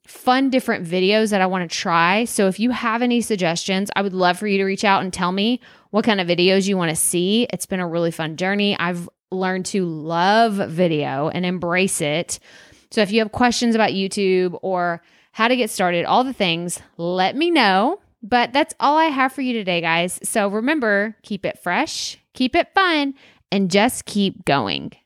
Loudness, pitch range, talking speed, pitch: -19 LUFS, 180-230 Hz, 205 wpm, 195 Hz